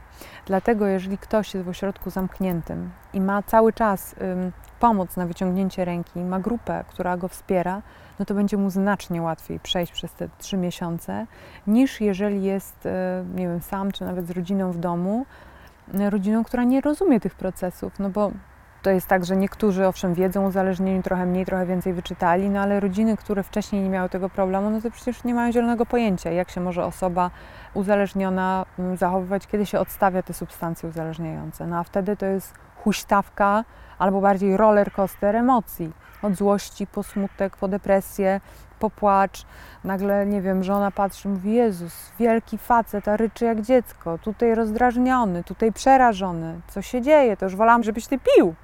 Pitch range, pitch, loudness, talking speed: 185-210 Hz, 195 Hz, -23 LUFS, 175 wpm